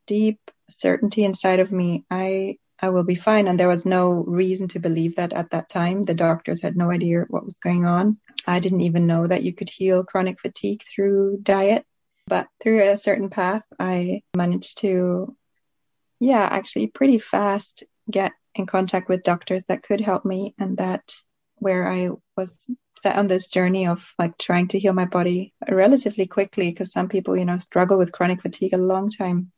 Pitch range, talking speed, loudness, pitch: 180-200 Hz, 190 wpm, -22 LUFS, 185 Hz